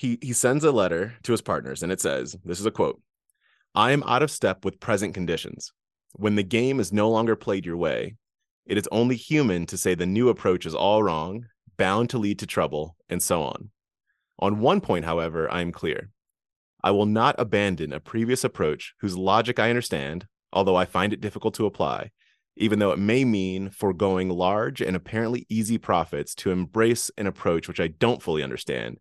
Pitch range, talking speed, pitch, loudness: 90-115 Hz, 200 wpm, 105 Hz, -25 LUFS